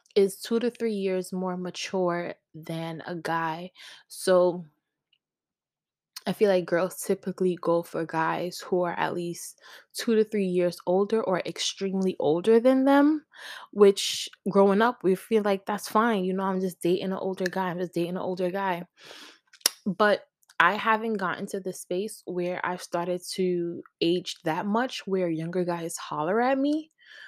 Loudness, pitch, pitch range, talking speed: -26 LUFS, 185 Hz, 175-205 Hz, 165 wpm